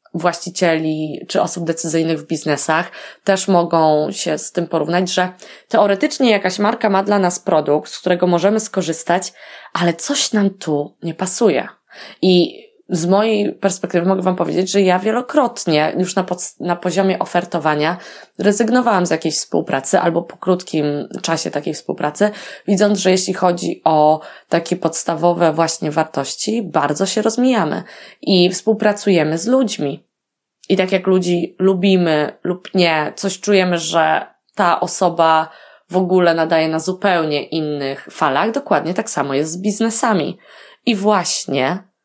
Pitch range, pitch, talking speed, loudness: 165-200 Hz, 180 Hz, 140 wpm, -16 LUFS